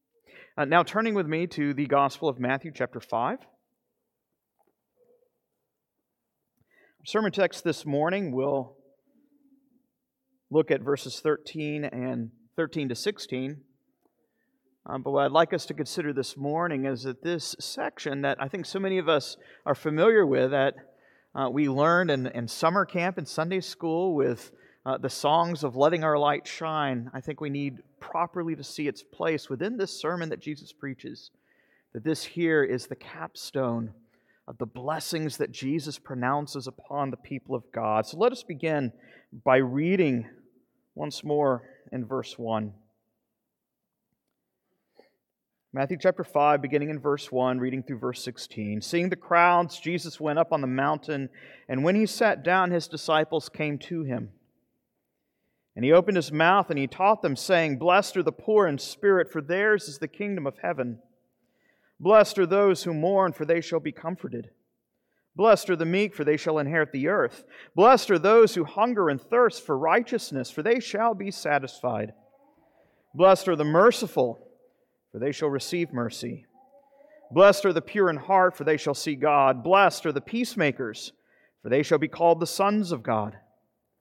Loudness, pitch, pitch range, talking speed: -25 LUFS, 155 Hz, 135-185 Hz, 165 wpm